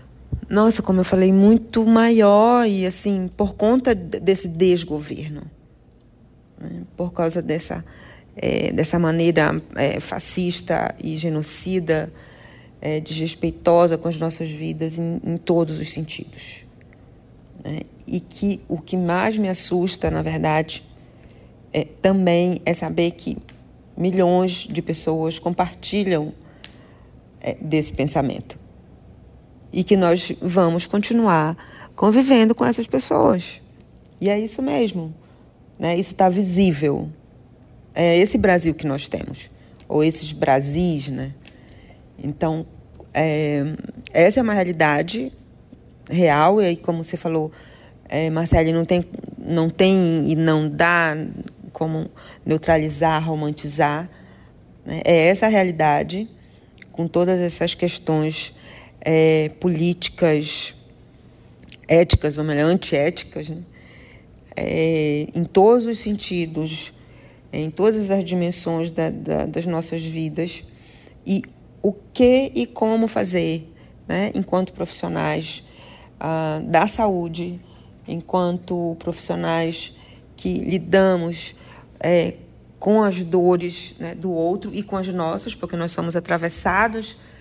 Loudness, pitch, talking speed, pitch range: -20 LUFS, 170 Hz, 115 wpm, 155-185 Hz